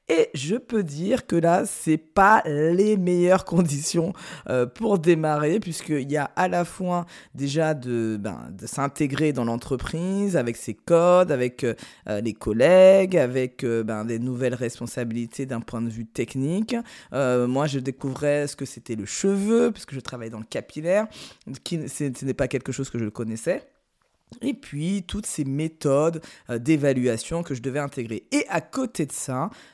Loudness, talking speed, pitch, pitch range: -24 LUFS, 165 wpm, 150 Hz, 125-175 Hz